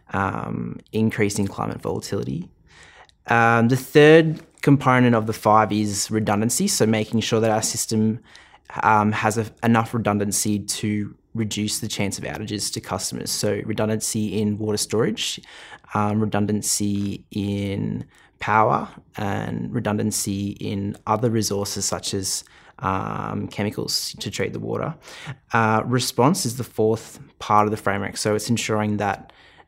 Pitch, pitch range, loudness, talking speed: 110 Hz, 105-115 Hz, -22 LUFS, 135 wpm